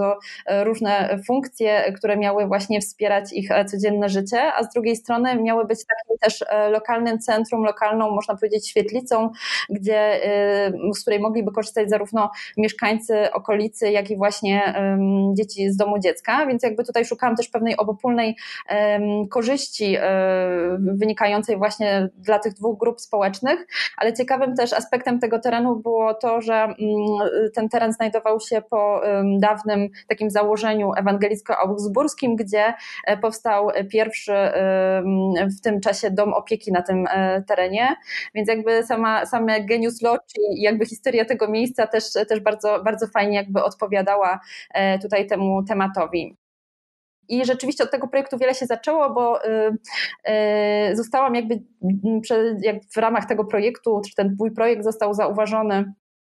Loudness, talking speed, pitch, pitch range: -21 LUFS, 130 wpm, 215 Hz, 205-230 Hz